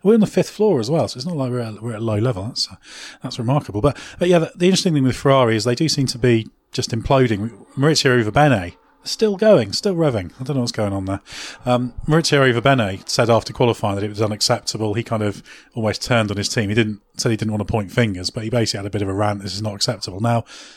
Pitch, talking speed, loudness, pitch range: 120 Hz, 270 wpm, -19 LUFS, 105-140 Hz